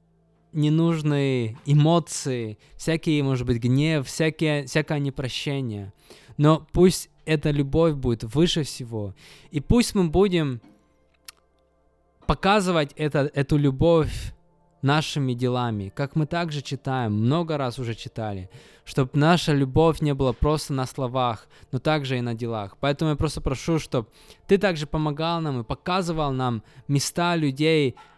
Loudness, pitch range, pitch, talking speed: -24 LUFS, 125-160 Hz, 145 Hz, 130 wpm